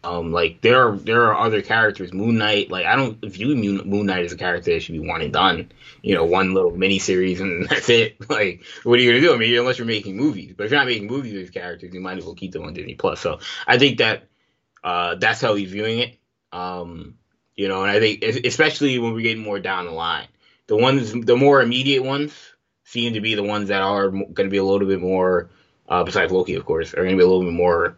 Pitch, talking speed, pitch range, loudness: 105 Hz, 255 wpm, 95-120 Hz, -19 LUFS